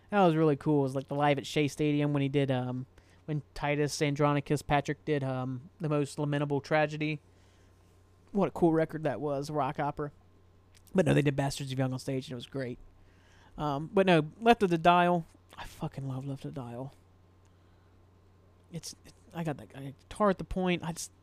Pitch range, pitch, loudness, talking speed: 100-150 Hz, 140 Hz, -30 LUFS, 205 wpm